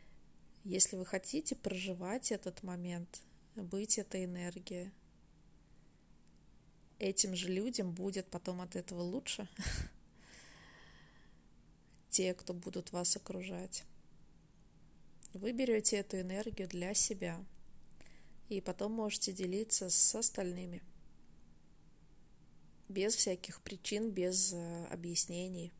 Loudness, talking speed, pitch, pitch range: -33 LUFS, 90 wpm, 185 Hz, 180-205 Hz